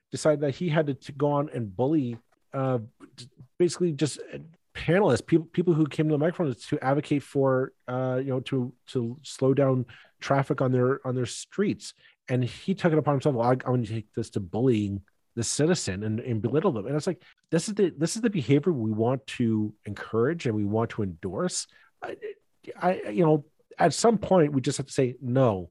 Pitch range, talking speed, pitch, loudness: 120-160 Hz, 210 wpm, 135 Hz, -27 LUFS